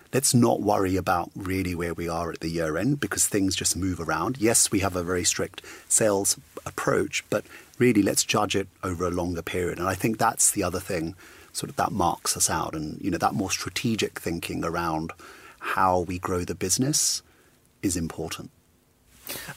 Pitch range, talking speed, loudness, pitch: 85-100 Hz, 190 wpm, -25 LUFS, 90 Hz